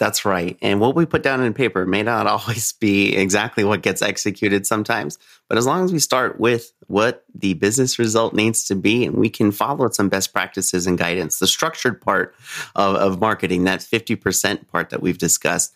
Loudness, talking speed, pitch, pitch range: -19 LUFS, 200 wpm, 105 Hz, 100-115 Hz